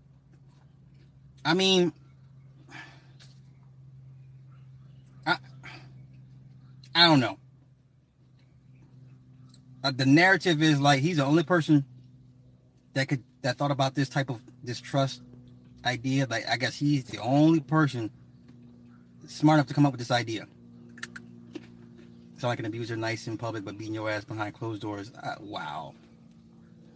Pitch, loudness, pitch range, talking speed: 130 Hz, -26 LUFS, 120-140 Hz, 120 wpm